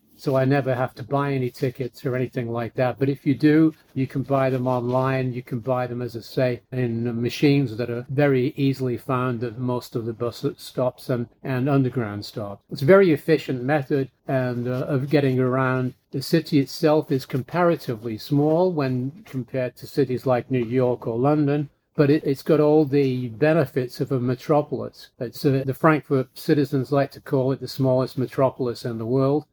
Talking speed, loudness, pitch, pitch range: 195 wpm, -23 LUFS, 130 Hz, 125-145 Hz